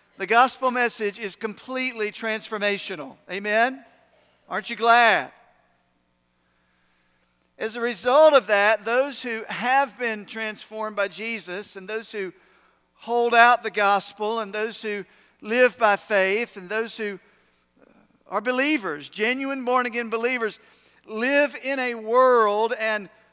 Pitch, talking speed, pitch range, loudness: 220 Hz, 125 wpm, 205-245 Hz, -23 LUFS